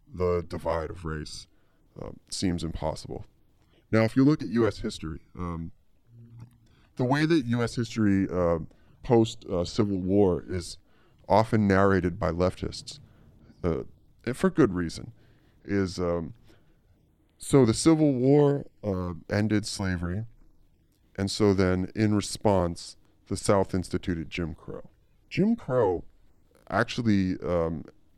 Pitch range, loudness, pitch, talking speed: 90-115 Hz, -27 LUFS, 100 Hz, 120 wpm